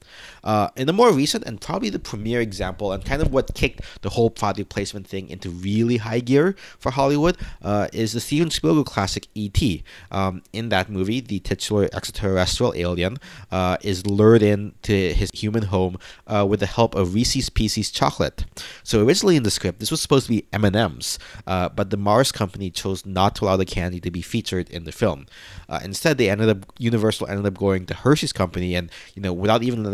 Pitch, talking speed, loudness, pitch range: 100 Hz, 205 wpm, -22 LUFS, 95-115 Hz